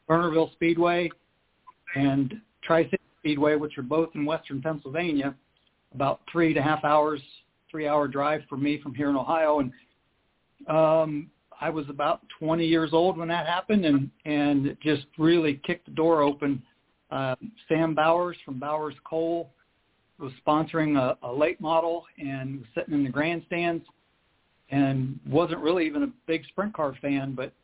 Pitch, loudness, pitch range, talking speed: 155 Hz, -26 LUFS, 140-165 Hz, 155 wpm